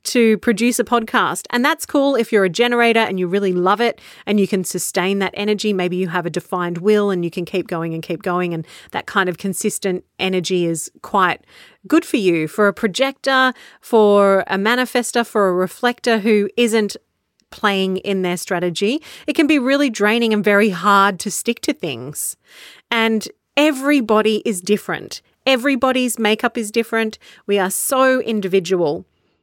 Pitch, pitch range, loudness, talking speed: 210 Hz, 185-240 Hz, -18 LUFS, 175 wpm